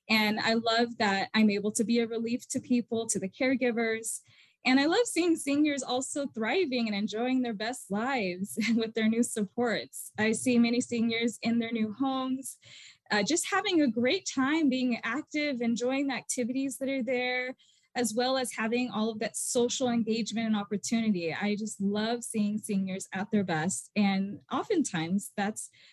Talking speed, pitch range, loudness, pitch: 175 wpm, 215-255 Hz, -29 LUFS, 235 Hz